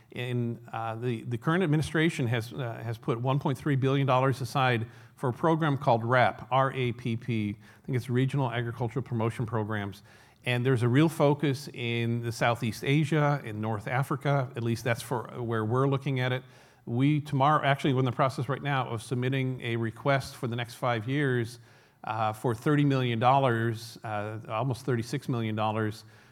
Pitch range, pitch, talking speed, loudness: 115-140 Hz, 125 Hz, 180 wpm, -29 LUFS